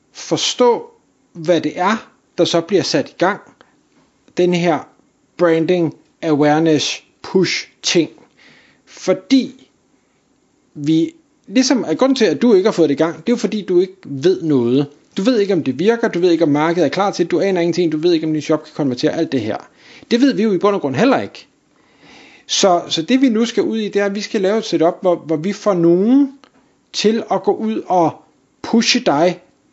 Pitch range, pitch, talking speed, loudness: 160-220 Hz, 180 Hz, 210 wpm, -16 LUFS